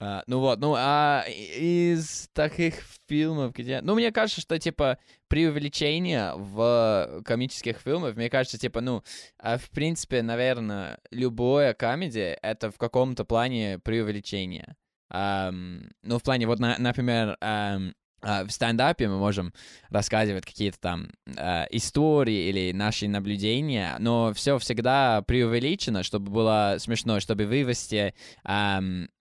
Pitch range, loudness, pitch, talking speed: 105-135 Hz, -26 LUFS, 115 Hz, 135 wpm